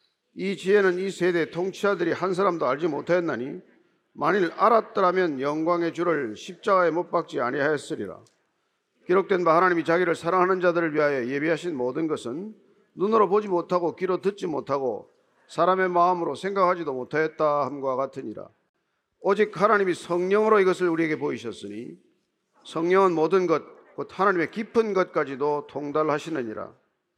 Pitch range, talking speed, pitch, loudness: 160-190 Hz, 355 characters per minute, 175 Hz, -24 LUFS